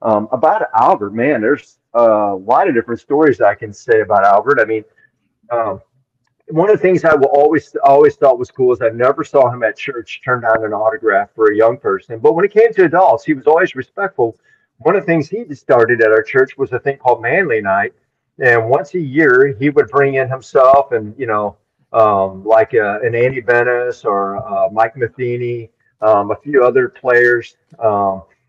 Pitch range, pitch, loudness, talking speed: 115-165 Hz, 130 Hz, -14 LUFS, 205 wpm